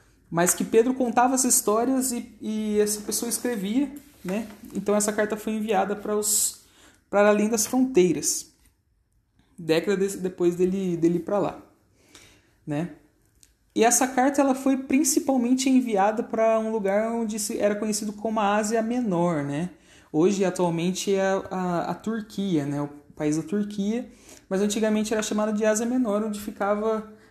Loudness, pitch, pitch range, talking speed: -24 LUFS, 210 Hz, 180-230 Hz, 155 wpm